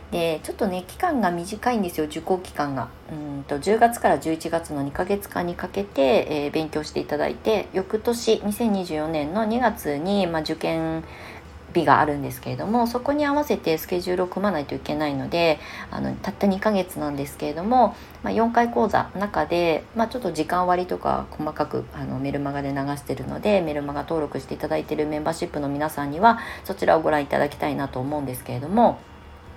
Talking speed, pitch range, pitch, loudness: 390 characters per minute, 145-200 Hz, 160 Hz, -24 LUFS